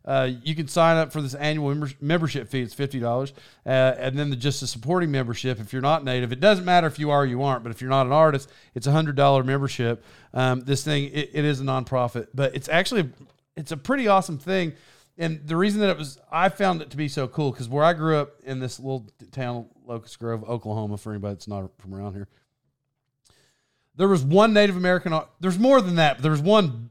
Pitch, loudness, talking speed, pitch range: 140 Hz, -23 LUFS, 235 wpm, 130-160 Hz